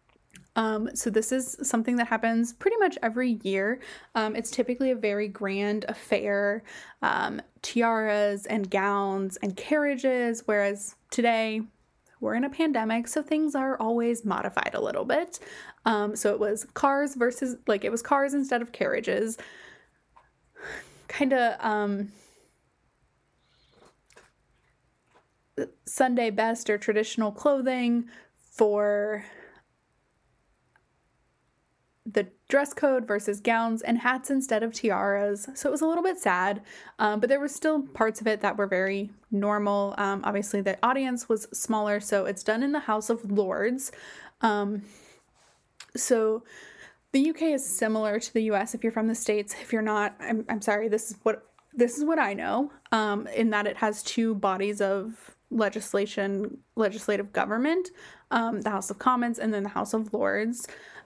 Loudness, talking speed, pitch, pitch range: -27 LUFS, 150 wpm, 225 Hz, 210-250 Hz